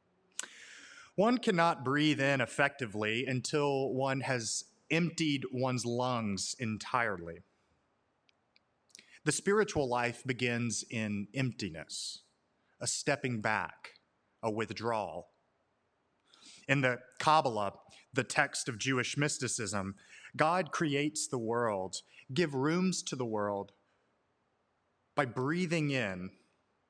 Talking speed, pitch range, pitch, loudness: 95 wpm, 115-145 Hz, 130 Hz, -33 LUFS